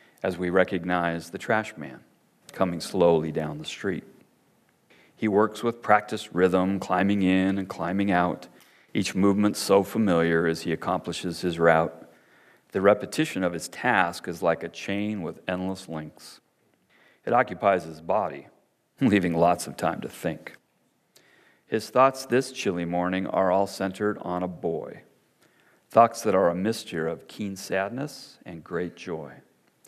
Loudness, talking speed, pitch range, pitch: -26 LUFS, 150 wpm, 85-100 Hz, 95 Hz